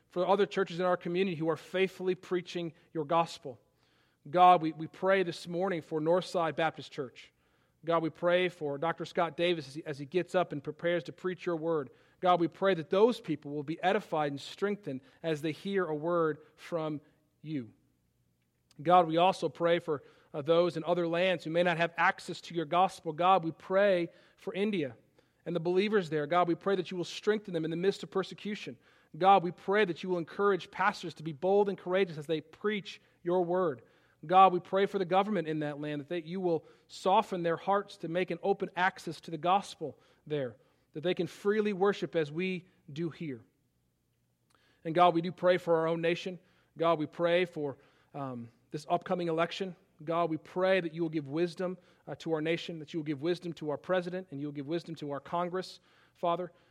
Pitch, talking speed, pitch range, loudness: 170 Hz, 210 wpm, 160-185 Hz, -31 LUFS